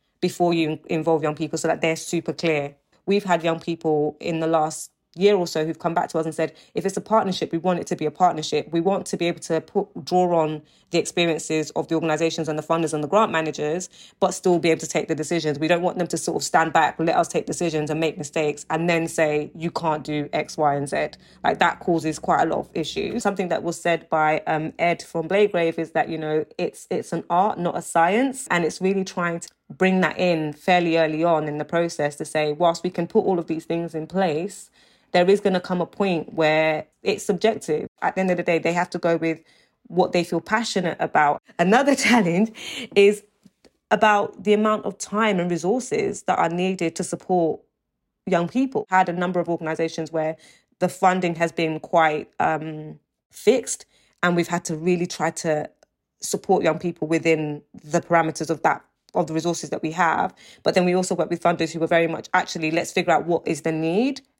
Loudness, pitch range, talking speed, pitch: -22 LUFS, 160-185 Hz, 225 wpm, 170 Hz